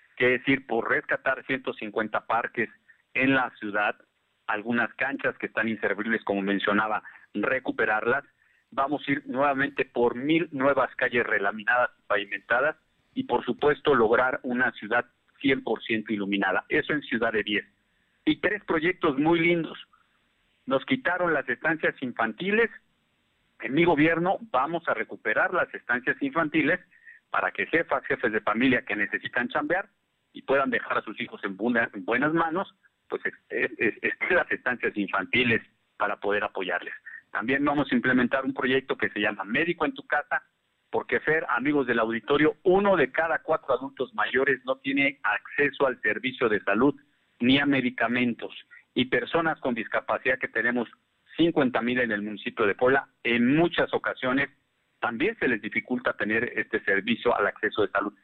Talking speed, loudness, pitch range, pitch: 155 wpm, -26 LUFS, 120-185 Hz, 140 Hz